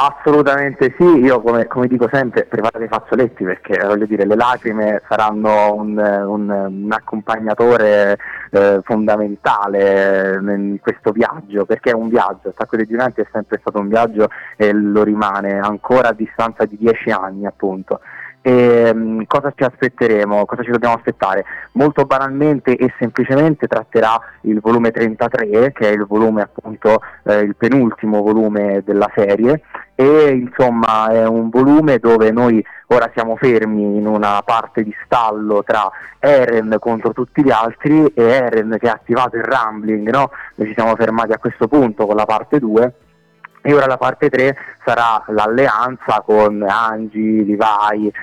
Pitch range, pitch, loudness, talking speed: 105-125 Hz, 110 Hz, -15 LUFS, 155 wpm